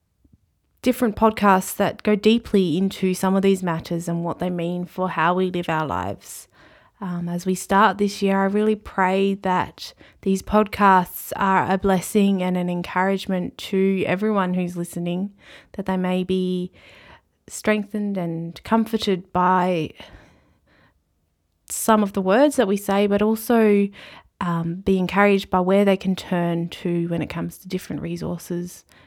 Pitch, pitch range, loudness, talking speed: 185 Hz, 175-200 Hz, -21 LUFS, 155 wpm